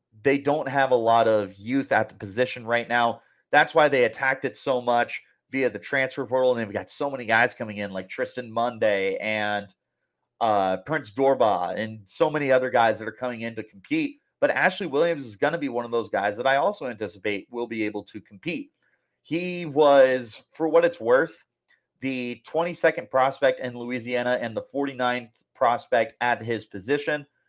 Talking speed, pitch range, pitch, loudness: 190 wpm, 110-135 Hz, 125 Hz, -24 LUFS